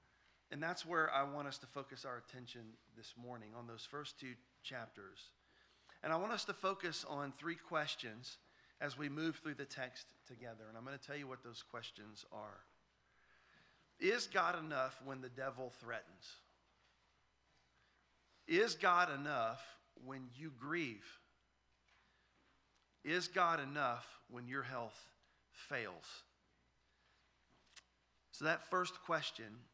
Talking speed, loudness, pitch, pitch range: 135 wpm, -42 LUFS, 135 Hz, 120-155 Hz